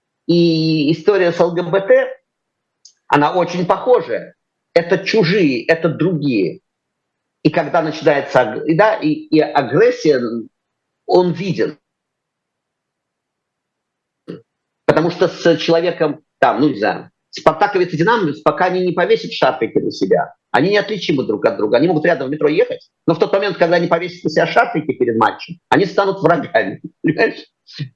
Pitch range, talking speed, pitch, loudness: 165-205 Hz, 140 wpm, 180 Hz, -16 LUFS